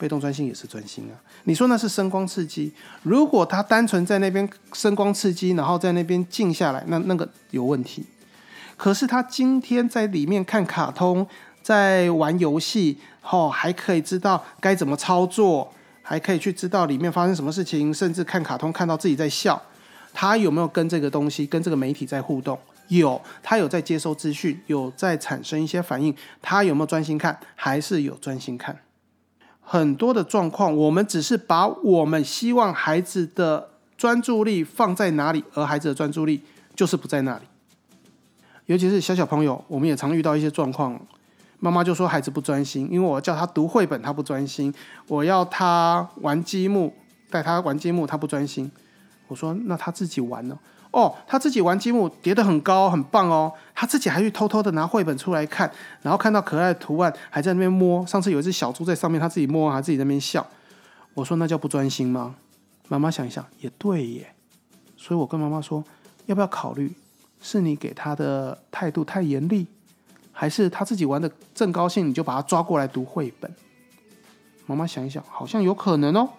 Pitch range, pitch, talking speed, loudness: 150-190 Hz, 165 Hz, 290 characters per minute, -23 LUFS